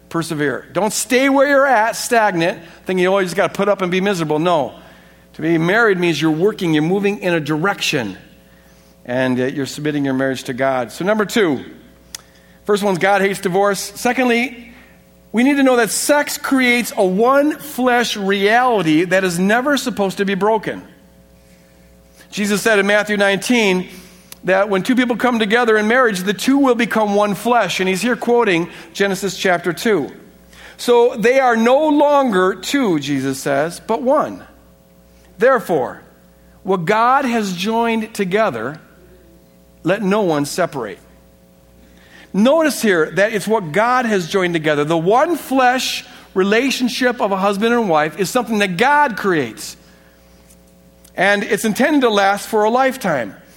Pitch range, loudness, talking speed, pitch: 155-235 Hz, -16 LUFS, 155 wpm, 200 Hz